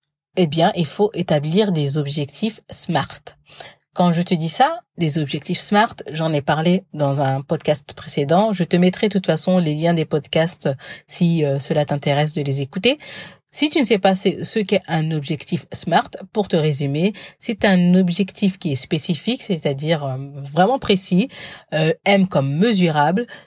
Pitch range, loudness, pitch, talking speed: 150-195 Hz, -19 LUFS, 170 Hz, 165 wpm